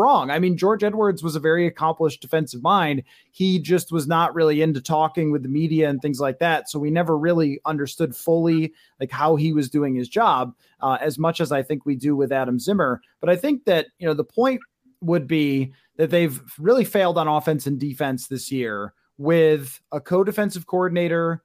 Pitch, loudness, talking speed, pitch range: 160 Hz, -21 LUFS, 205 wpm, 145-170 Hz